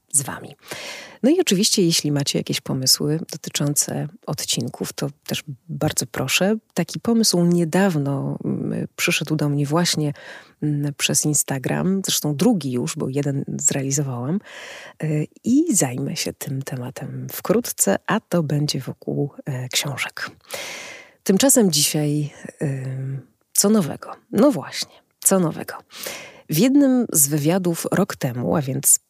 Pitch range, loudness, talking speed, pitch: 140-185 Hz, -21 LUFS, 120 wpm, 155 Hz